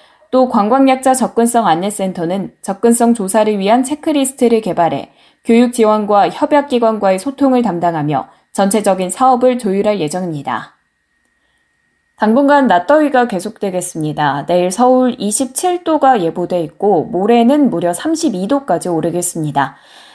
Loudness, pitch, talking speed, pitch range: -13 LUFS, 215 Hz, 305 characters per minute, 180-255 Hz